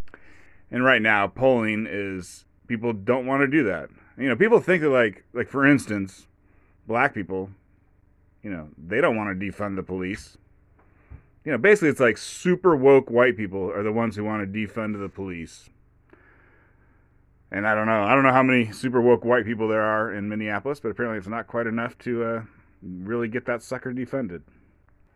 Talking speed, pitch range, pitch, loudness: 190 wpm, 95-120 Hz, 110 Hz, -23 LUFS